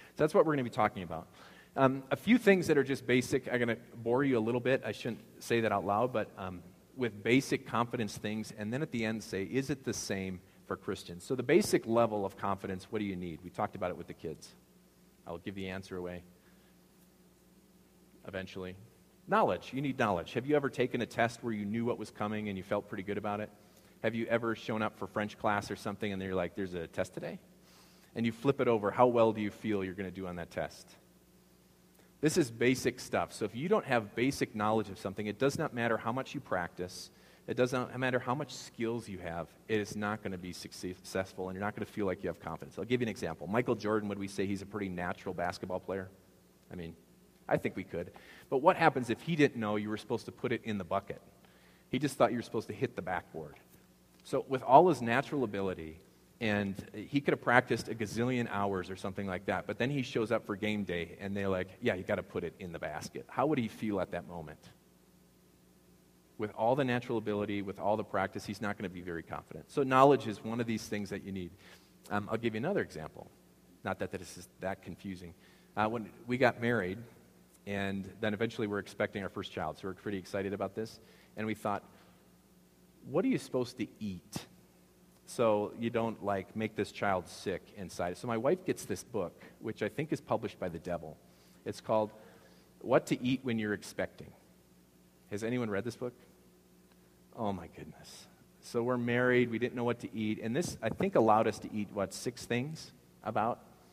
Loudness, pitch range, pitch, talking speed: -34 LUFS, 90-115 Hz, 105 Hz, 225 wpm